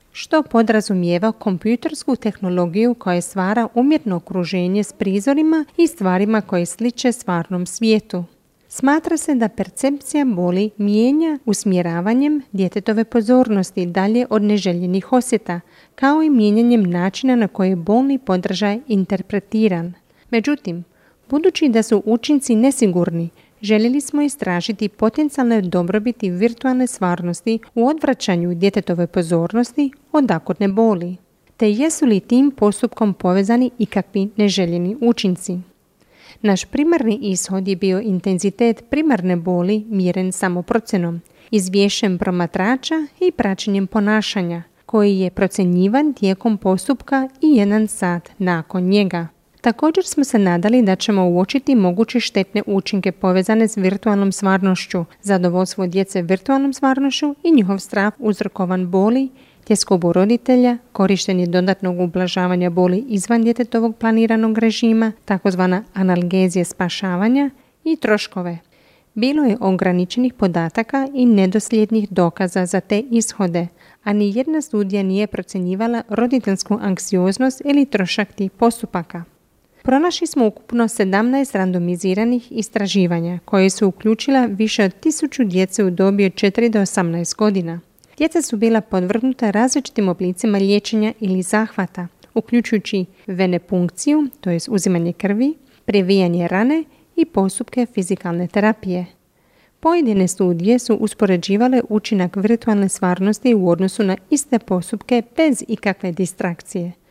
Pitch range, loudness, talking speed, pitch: 185-240 Hz, -18 LUFS, 115 wpm, 210 Hz